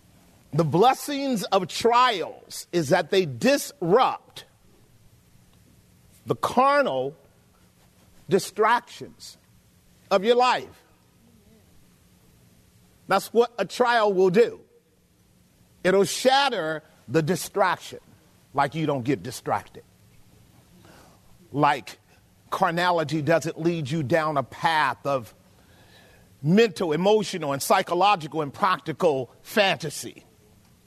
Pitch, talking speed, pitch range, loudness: 175 Hz, 85 wpm, 140-230 Hz, -23 LUFS